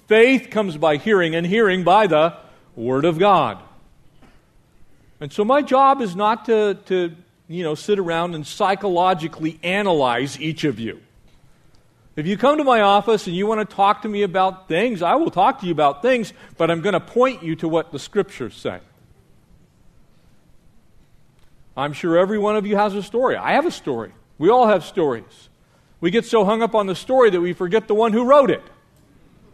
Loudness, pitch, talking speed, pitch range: -19 LUFS, 195 Hz, 195 wpm, 165-220 Hz